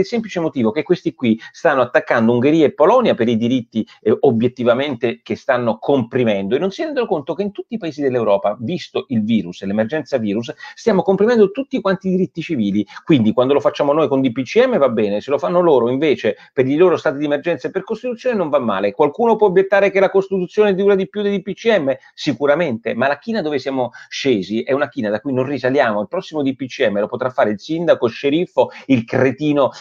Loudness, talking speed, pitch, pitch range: -17 LUFS, 210 wpm, 155 Hz, 125-195 Hz